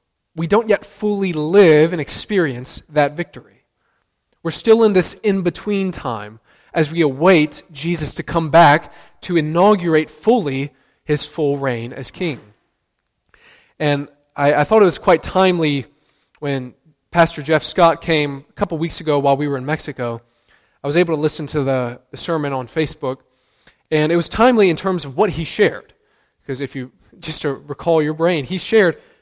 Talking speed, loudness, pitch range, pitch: 175 wpm, -17 LUFS, 140-175 Hz, 155 Hz